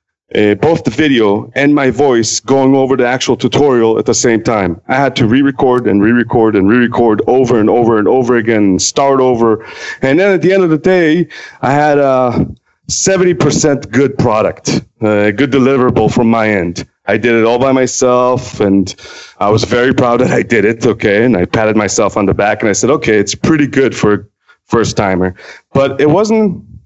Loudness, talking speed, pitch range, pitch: -11 LUFS, 195 wpm, 110-140 Hz, 125 Hz